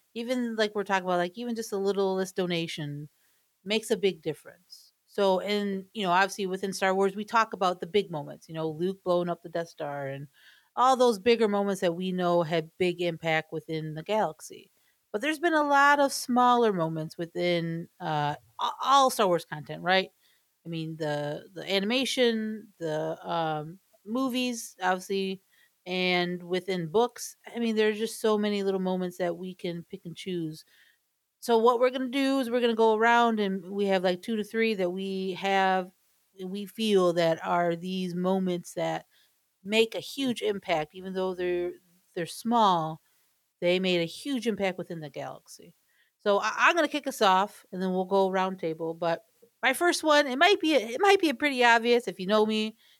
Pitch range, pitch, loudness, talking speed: 175-225 Hz, 190 Hz, -27 LUFS, 190 wpm